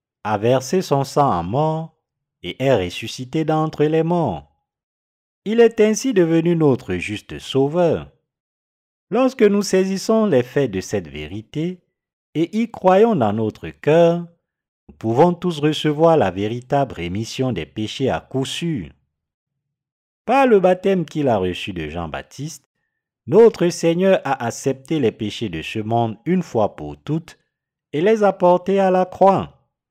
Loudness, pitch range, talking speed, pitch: -19 LUFS, 110-175 Hz, 145 wpm, 145 Hz